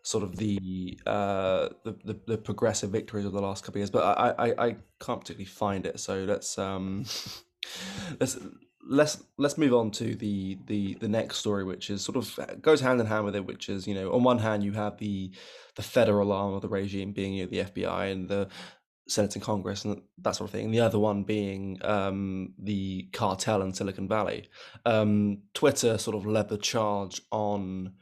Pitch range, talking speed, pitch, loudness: 95-110 Hz, 210 wpm, 100 Hz, -29 LUFS